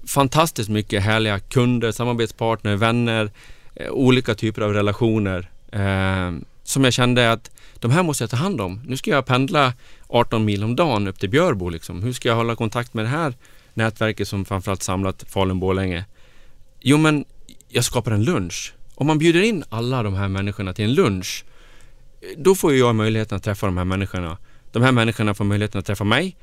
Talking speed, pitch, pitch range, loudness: 185 wpm, 110 Hz, 100-125 Hz, -20 LUFS